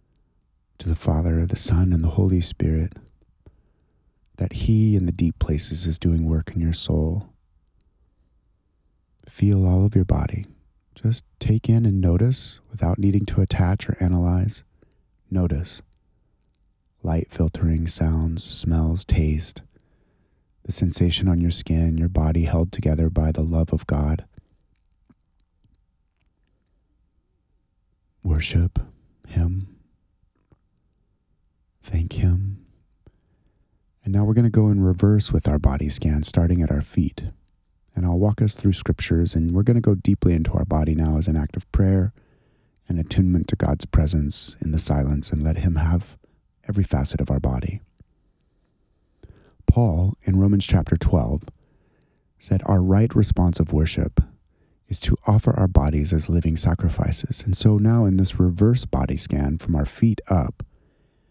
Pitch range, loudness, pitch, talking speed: 80-100 Hz, -22 LUFS, 90 Hz, 145 wpm